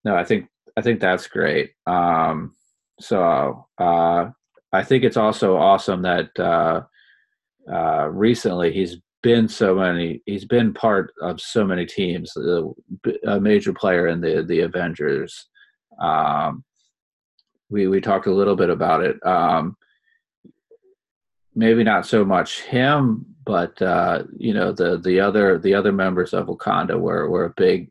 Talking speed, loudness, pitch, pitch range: 150 wpm, -20 LUFS, 105 Hz, 90-130 Hz